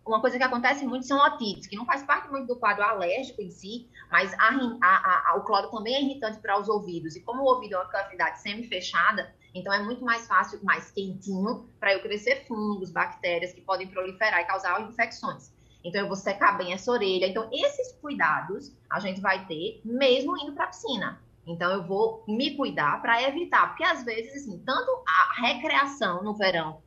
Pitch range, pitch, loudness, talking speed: 185-255 Hz, 215 Hz, -26 LUFS, 200 wpm